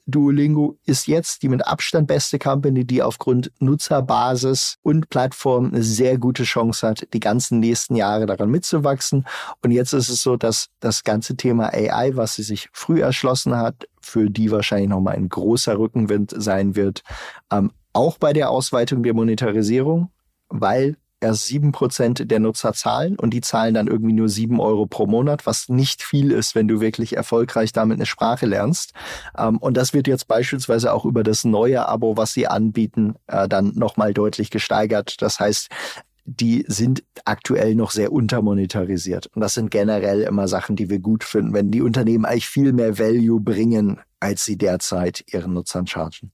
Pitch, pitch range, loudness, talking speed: 115 Hz, 105-125 Hz, -19 LUFS, 175 wpm